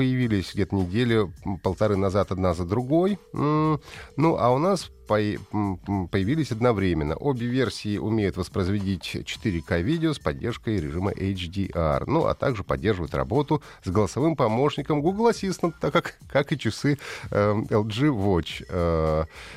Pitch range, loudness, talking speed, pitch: 95-145 Hz, -25 LUFS, 130 wpm, 105 Hz